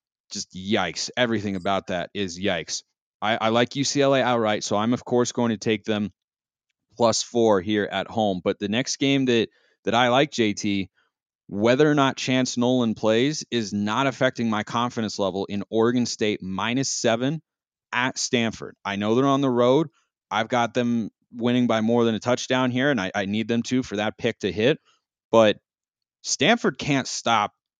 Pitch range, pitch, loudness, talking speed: 105-125 Hz, 115 Hz, -23 LUFS, 180 wpm